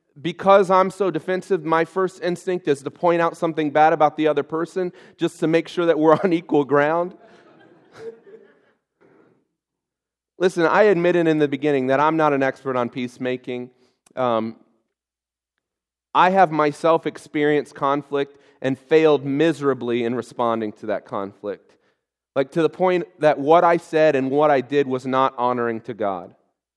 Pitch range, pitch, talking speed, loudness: 135-170 Hz, 150 Hz, 155 wpm, -20 LUFS